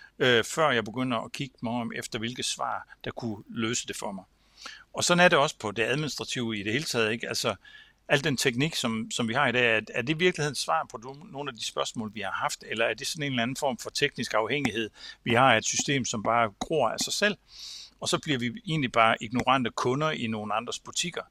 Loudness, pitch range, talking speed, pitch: -27 LUFS, 115-150 Hz, 240 wpm, 125 Hz